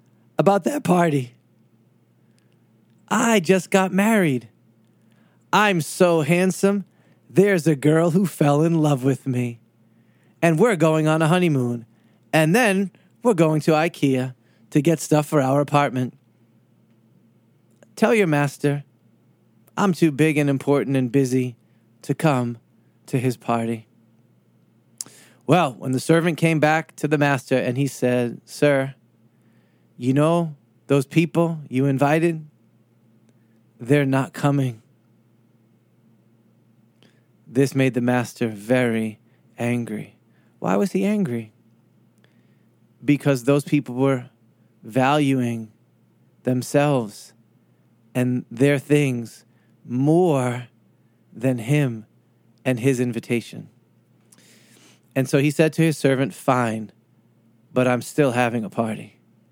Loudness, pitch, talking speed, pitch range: -21 LUFS, 130 Hz, 115 wpm, 115-150 Hz